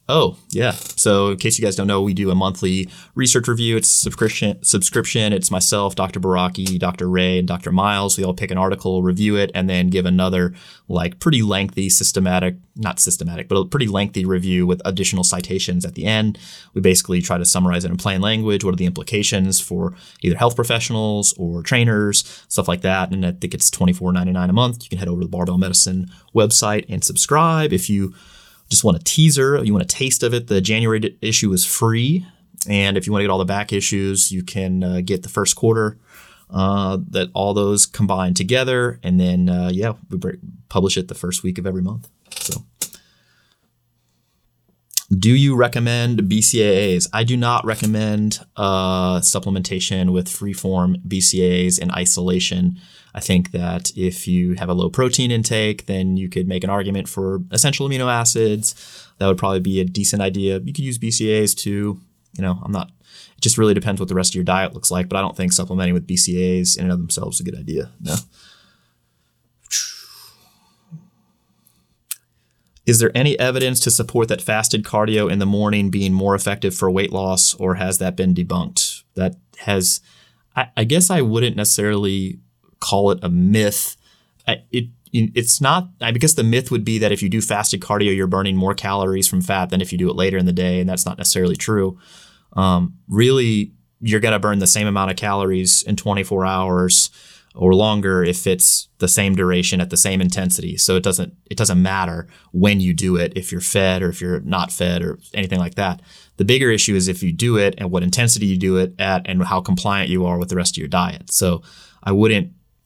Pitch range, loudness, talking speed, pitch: 90-105 Hz, -18 LUFS, 200 wpm, 95 Hz